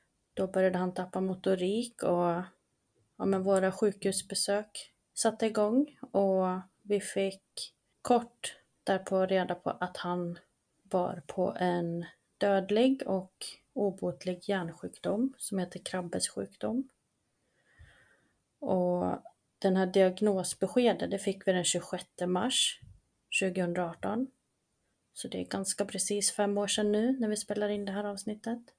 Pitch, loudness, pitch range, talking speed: 195 Hz, -32 LUFS, 185-210 Hz, 120 wpm